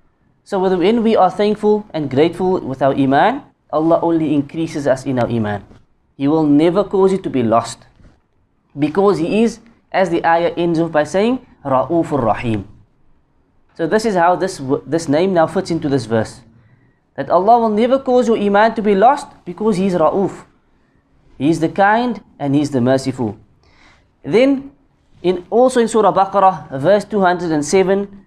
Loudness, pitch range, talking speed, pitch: -16 LUFS, 135-200 Hz, 170 wpm, 165 Hz